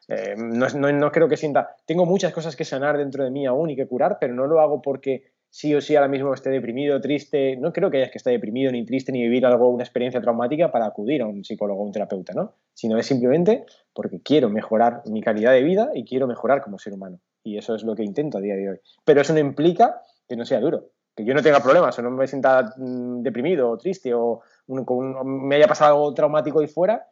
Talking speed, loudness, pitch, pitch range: 245 wpm, -21 LUFS, 135 Hz, 120-150 Hz